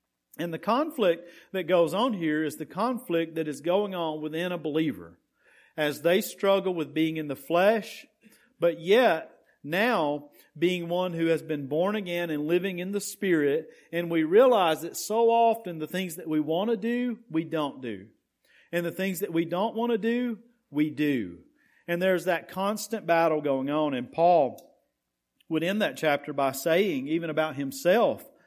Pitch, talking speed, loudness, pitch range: 170 Hz, 180 wpm, -27 LUFS, 155-200 Hz